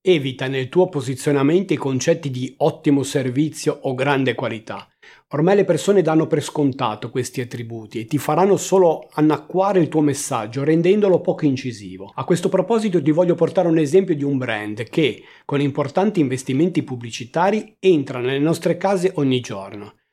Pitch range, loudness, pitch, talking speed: 130-175 Hz, -19 LUFS, 145 Hz, 160 wpm